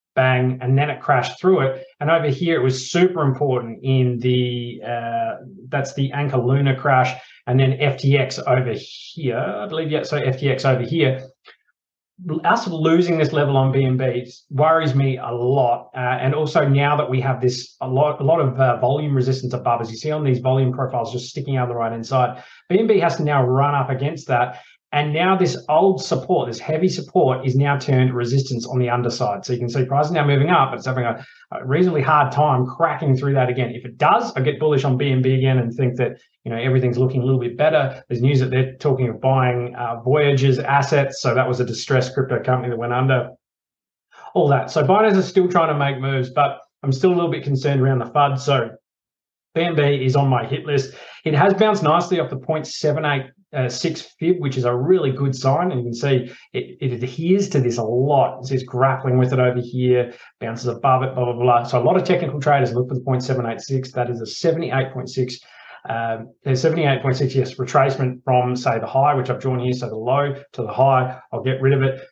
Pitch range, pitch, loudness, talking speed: 125-145 Hz, 130 Hz, -19 LUFS, 220 wpm